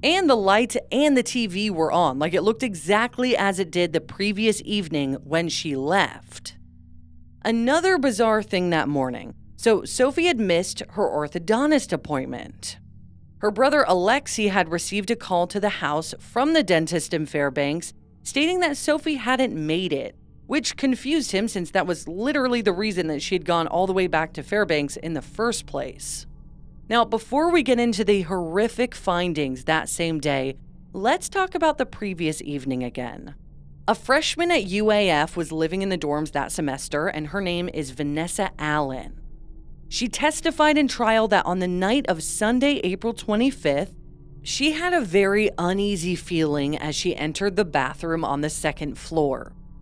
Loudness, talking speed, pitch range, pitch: -23 LUFS, 165 wpm, 155-235 Hz, 185 Hz